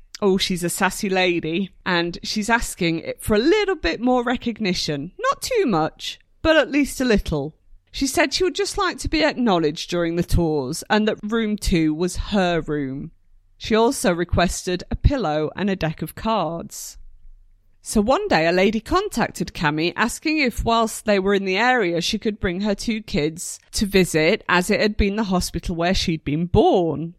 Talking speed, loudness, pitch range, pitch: 190 wpm, -21 LUFS, 165-225 Hz, 190 Hz